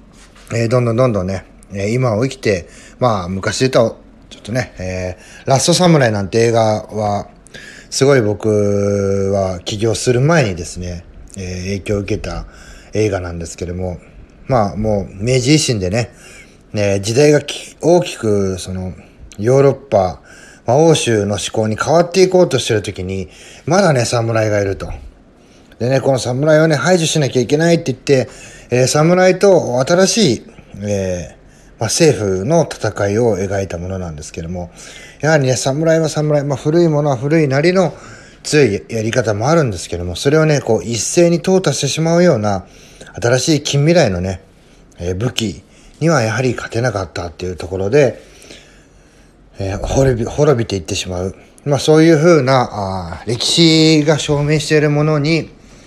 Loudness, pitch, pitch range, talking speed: -15 LUFS, 115 Hz, 95-150 Hz, 320 characters per minute